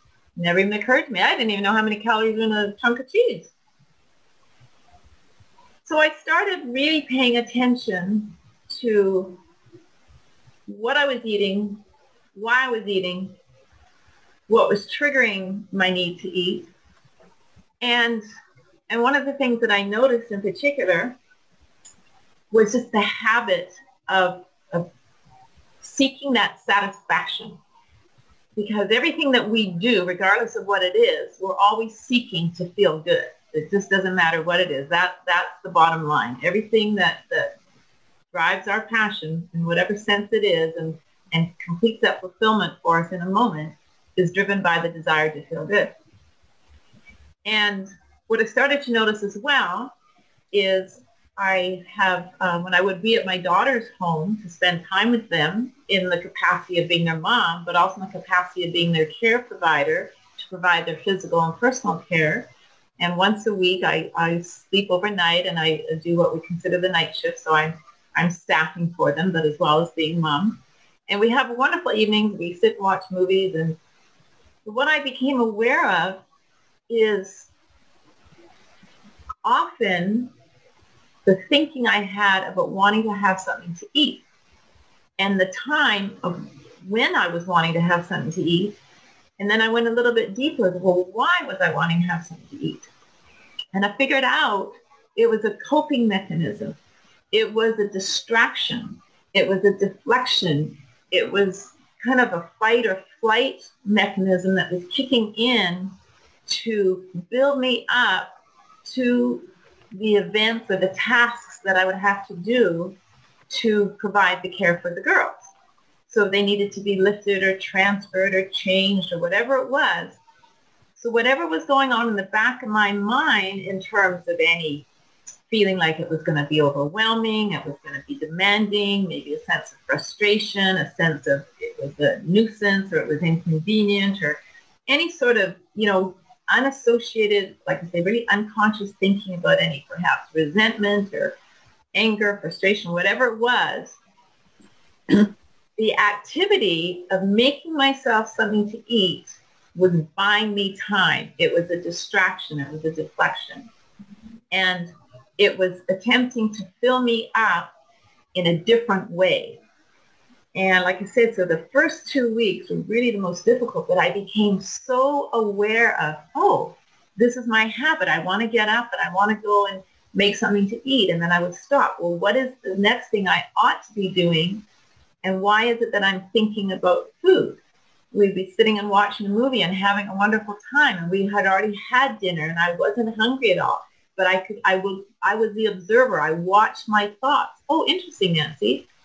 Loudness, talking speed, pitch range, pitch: -21 LUFS, 170 wpm, 180-235 Hz, 200 Hz